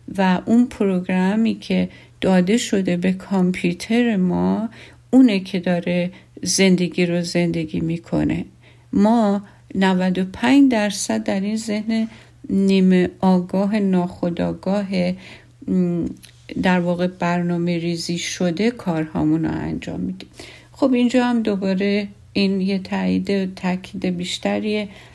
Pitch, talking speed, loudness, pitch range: 185 Hz, 105 wpm, -20 LUFS, 175-205 Hz